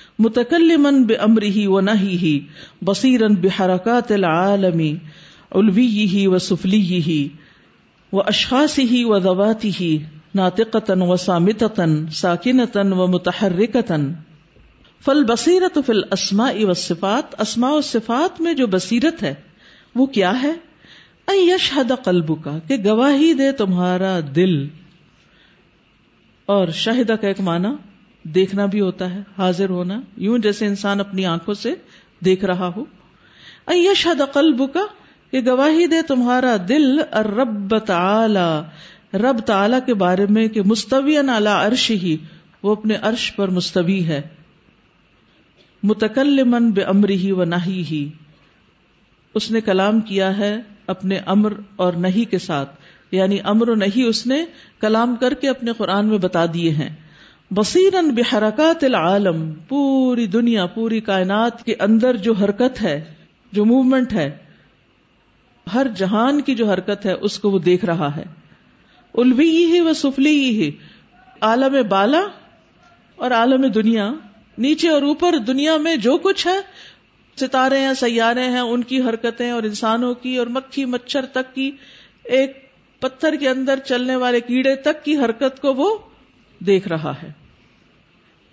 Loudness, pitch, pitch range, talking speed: -18 LUFS, 215 Hz, 185-260 Hz, 140 wpm